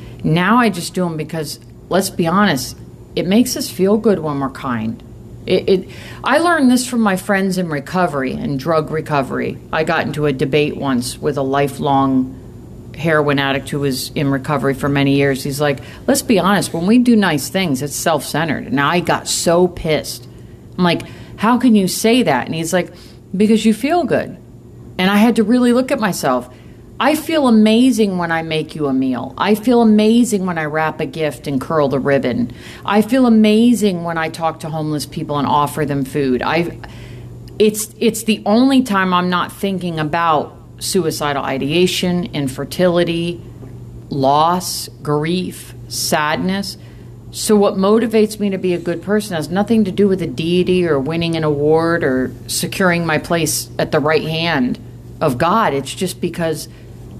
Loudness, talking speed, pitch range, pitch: -16 LUFS, 180 wpm, 140-200 Hz, 160 Hz